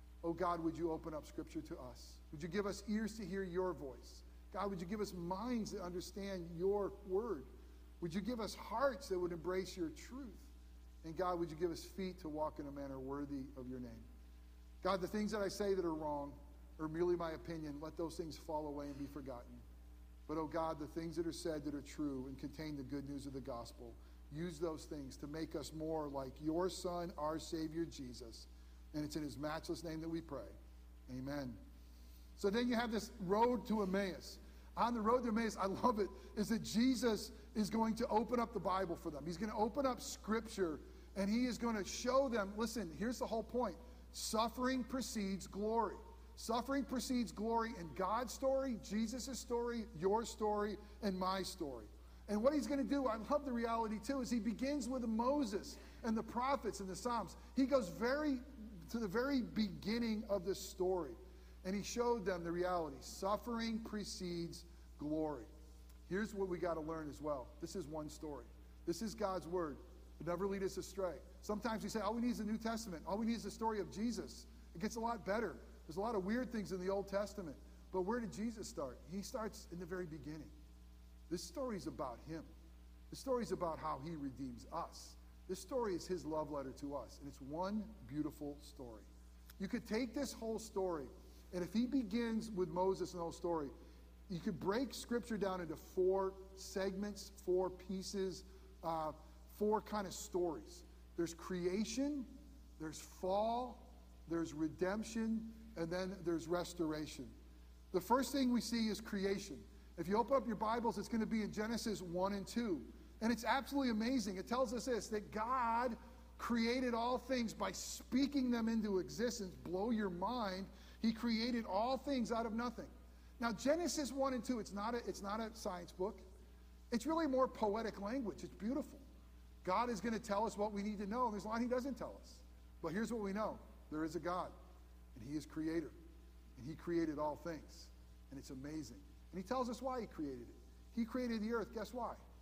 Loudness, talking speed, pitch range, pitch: -42 LUFS, 200 wpm, 155-225 Hz, 190 Hz